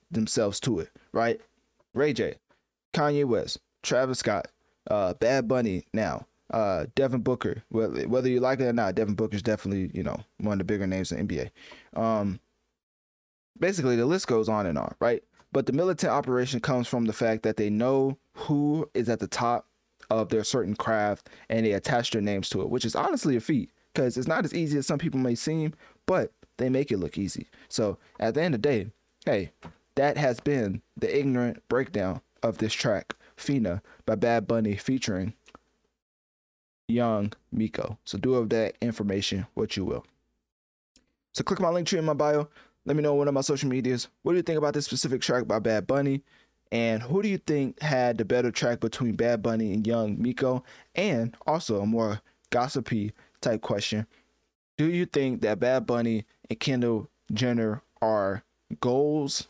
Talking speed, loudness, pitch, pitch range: 190 wpm, -28 LUFS, 120 Hz, 110-140 Hz